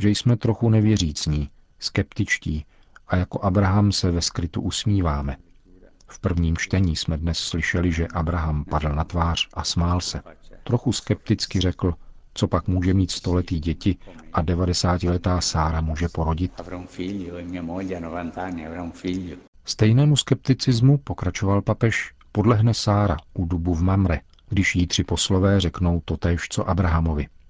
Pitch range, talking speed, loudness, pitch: 85-100 Hz, 130 wpm, -23 LUFS, 90 Hz